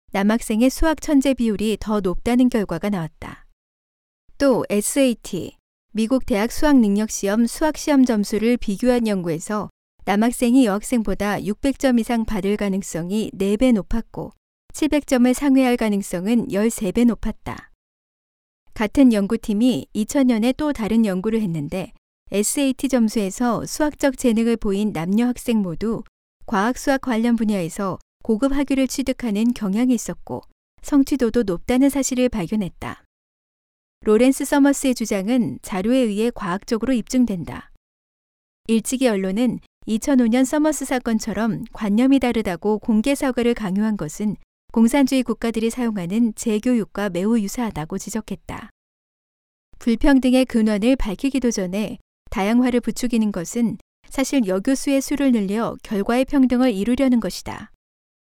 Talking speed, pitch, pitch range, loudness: 300 characters per minute, 230 Hz, 205-255 Hz, -20 LUFS